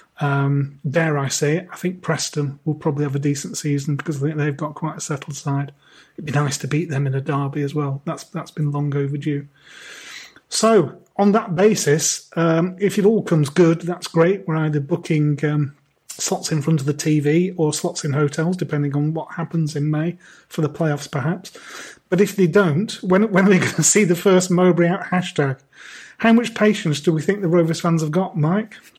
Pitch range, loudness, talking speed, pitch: 145-180 Hz, -20 LUFS, 210 wpm, 160 Hz